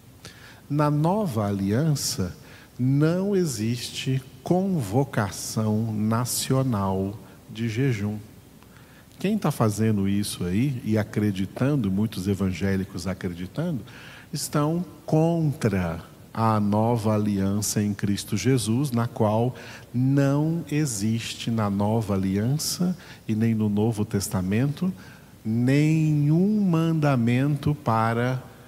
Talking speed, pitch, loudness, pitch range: 90 wpm, 115 Hz, -25 LUFS, 105-145 Hz